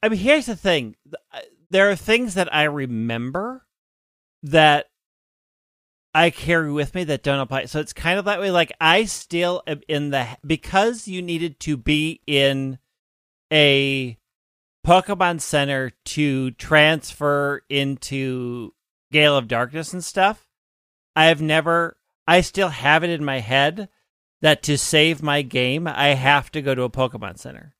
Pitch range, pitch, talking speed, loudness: 135-170 Hz, 150 Hz, 155 wpm, -19 LUFS